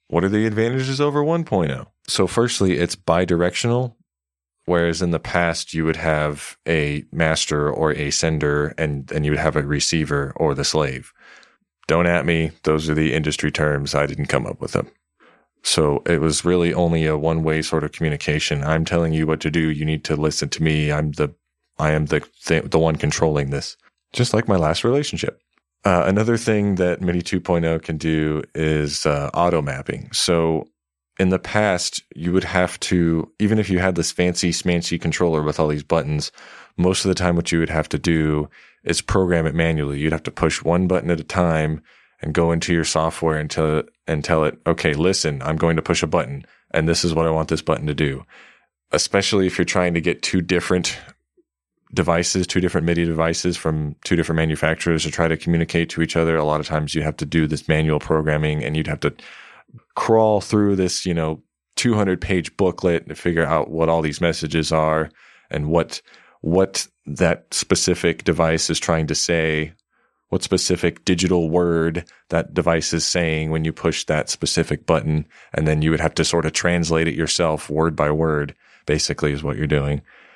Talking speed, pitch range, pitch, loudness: 195 wpm, 75-85 Hz, 80 Hz, -20 LUFS